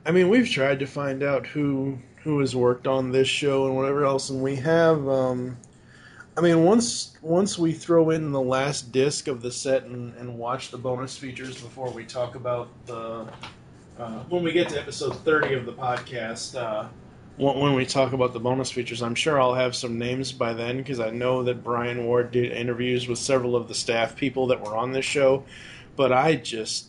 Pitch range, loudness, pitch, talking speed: 120-140 Hz, -24 LUFS, 130 Hz, 210 wpm